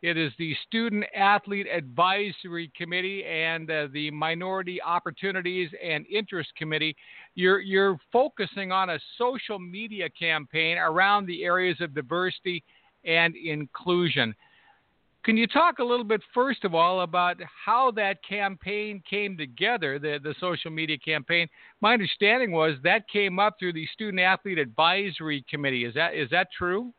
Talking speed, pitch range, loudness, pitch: 150 wpm, 160-200 Hz, -26 LUFS, 180 Hz